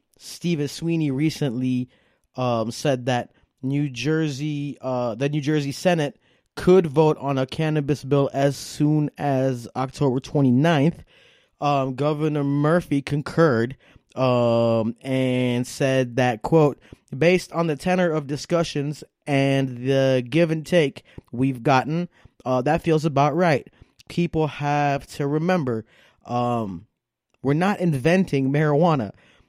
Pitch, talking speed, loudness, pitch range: 145 Hz, 120 wpm, -22 LUFS, 130-155 Hz